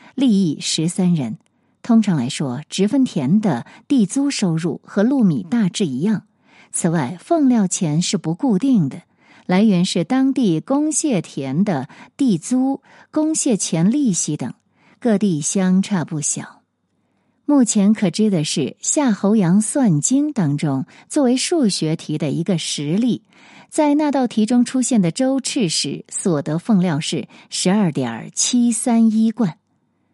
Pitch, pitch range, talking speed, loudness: 205 Hz, 175-245 Hz, 205 characters per minute, -18 LUFS